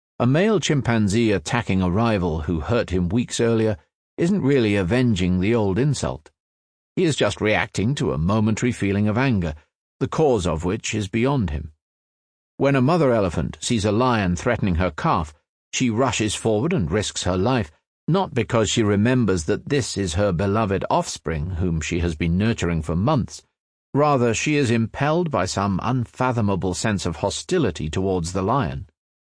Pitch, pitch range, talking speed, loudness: 105 Hz, 90-120 Hz, 165 wpm, -21 LUFS